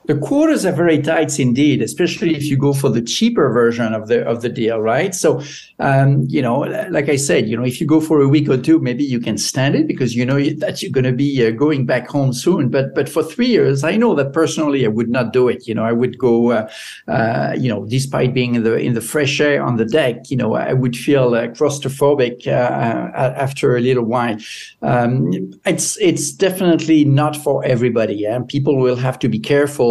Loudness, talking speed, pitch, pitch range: -16 LUFS, 235 wpm, 135 Hz, 120-150 Hz